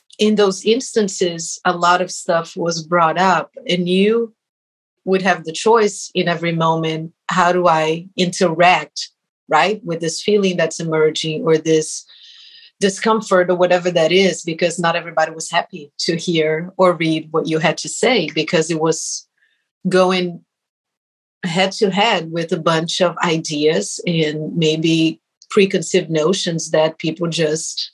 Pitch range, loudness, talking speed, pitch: 160-190 Hz, -17 LUFS, 150 wpm, 170 Hz